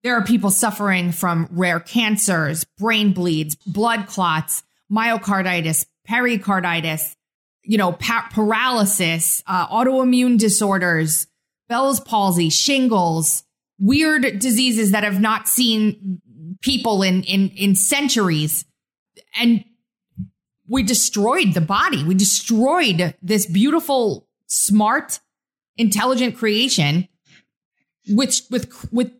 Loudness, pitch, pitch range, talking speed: -18 LUFS, 205 Hz, 175-235 Hz, 105 wpm